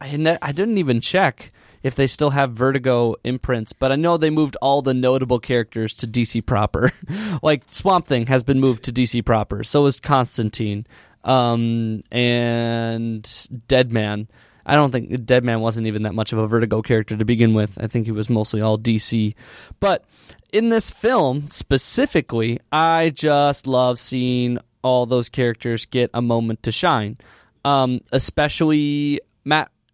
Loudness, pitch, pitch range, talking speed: -19 LUFS, 125 Hz, 115-140 Hz, 160 wpm